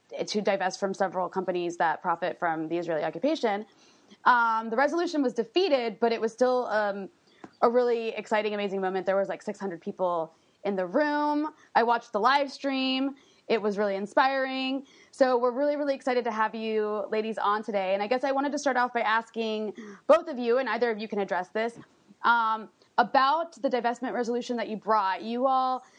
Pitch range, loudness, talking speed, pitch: 205-265 Hz, -27 LUFS, 195 wpm, 225 Hz